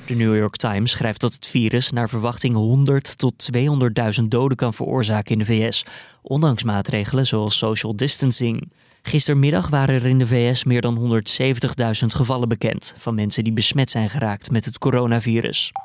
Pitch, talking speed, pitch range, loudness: 120 Hz, 165 wpm, 115-130 Hz, -19 LUFS